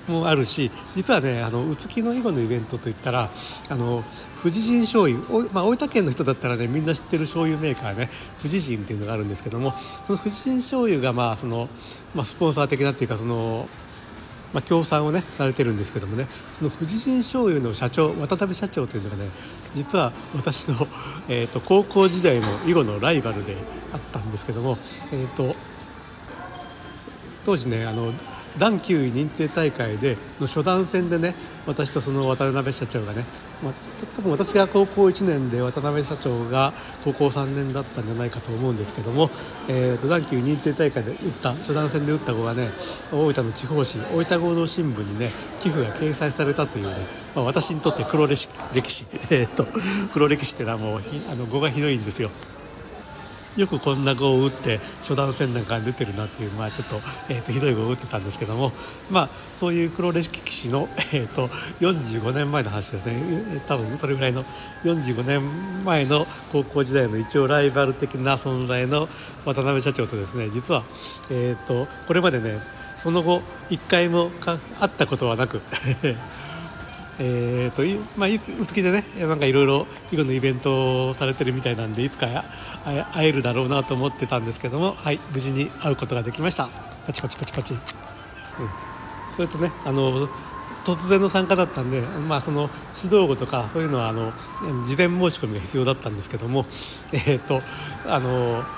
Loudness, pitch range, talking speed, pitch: -23 LUFS, 125-160 Hz, 355 characters per minute, 140 Hz